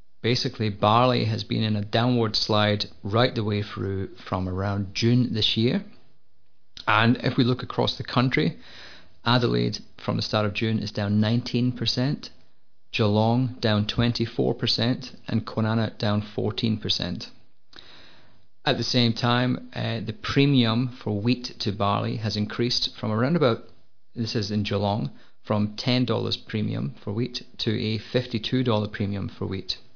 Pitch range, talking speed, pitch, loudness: 105-120 Hz, 140 wpm, 110 Hz, -25 LUFS